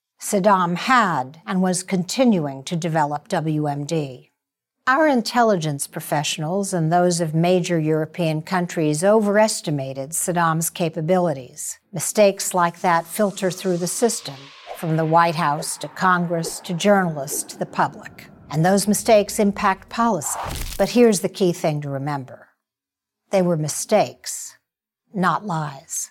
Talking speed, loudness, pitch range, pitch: 125 wpm, -21 LUFS, 155-195 Hz, 175 Hz